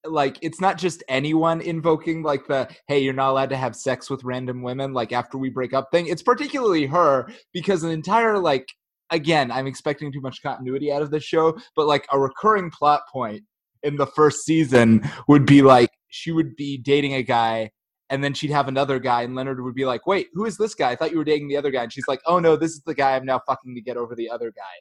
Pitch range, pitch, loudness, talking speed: 130-160 Hz, 140 Hz, -21 LUFS, 245 wpm